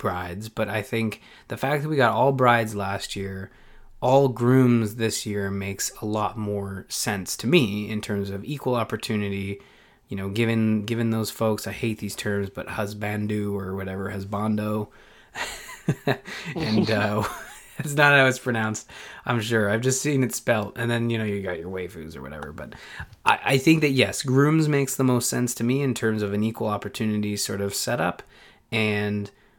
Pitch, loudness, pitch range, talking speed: 110 Hz, -24 LUFS, 100-120 Hz, 185 wpm